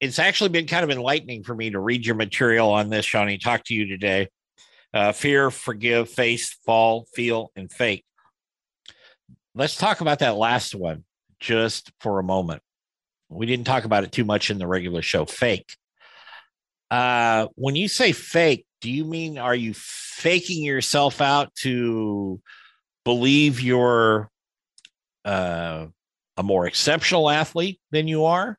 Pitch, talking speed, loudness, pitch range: 120 Hz, 155 wpm, -22 LUFS, 105-145 Hz